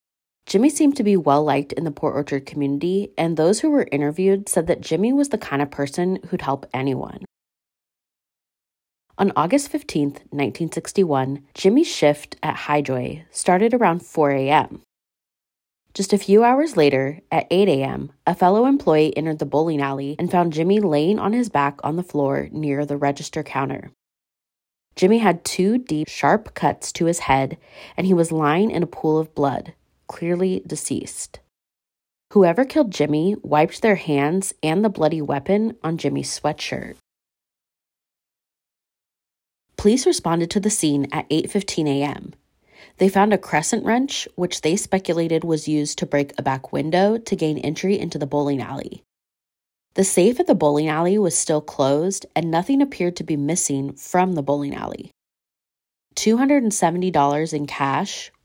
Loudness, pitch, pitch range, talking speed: -20 LUFS, 160 Hz, 145-195 Hz, 155 wpm